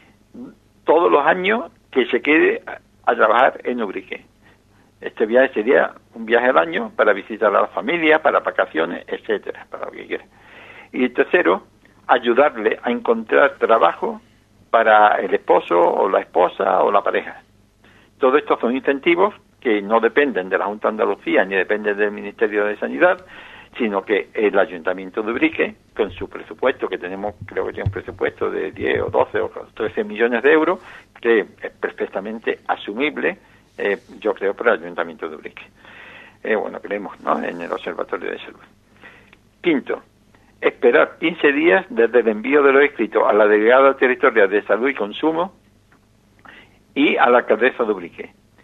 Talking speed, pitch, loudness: 165 wpm, 240 Hz, -18 LUFS